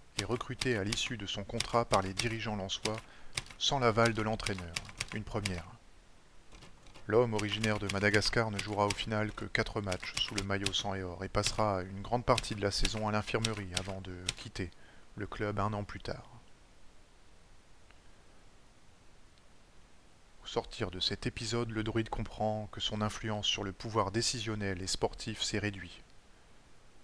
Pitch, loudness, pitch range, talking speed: 105 Hz, -34 LUFS, 95-115 Hz, 160 wpm